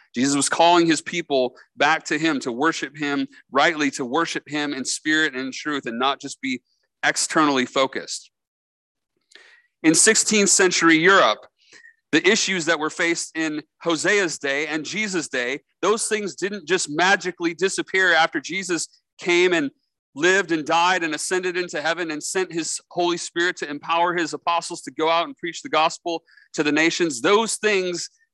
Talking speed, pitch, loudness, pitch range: 165 wpm, 170 Hz, -21 LUFS, 155-190 Hz